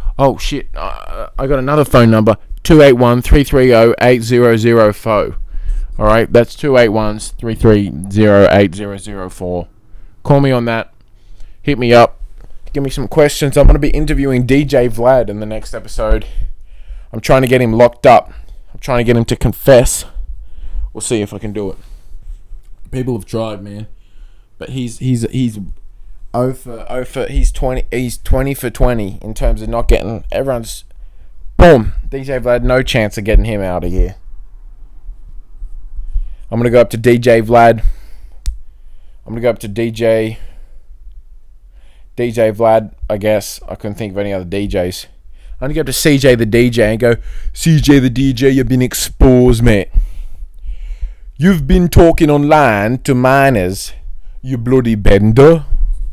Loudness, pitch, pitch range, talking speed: -12 LUFS, 110 Hz, 100-125 Hz, 150 wpm